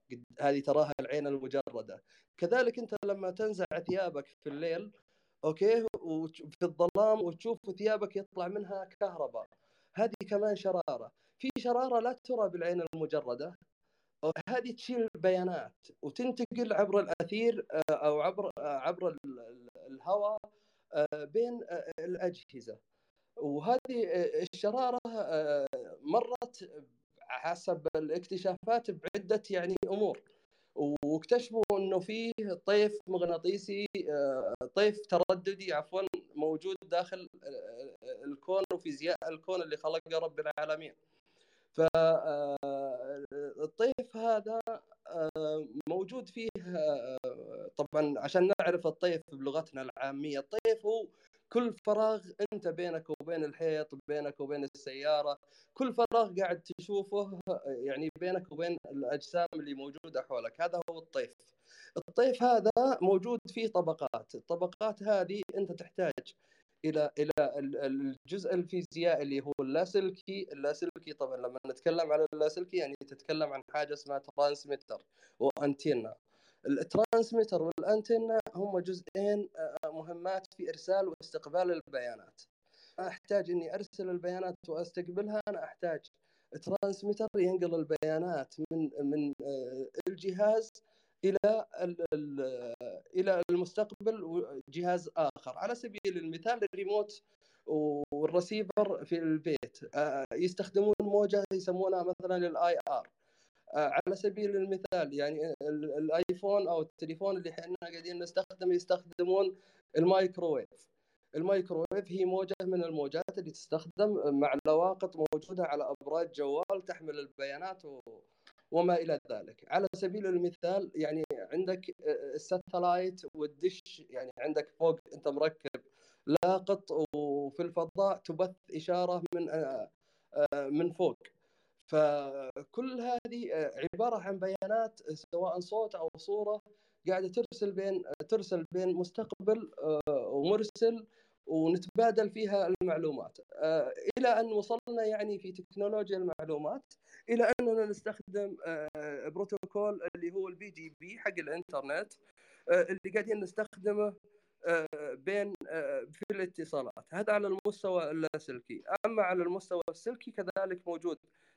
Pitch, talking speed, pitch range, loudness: 185 Hz, 100 wpm, 160-210 Hz, -34 LUFS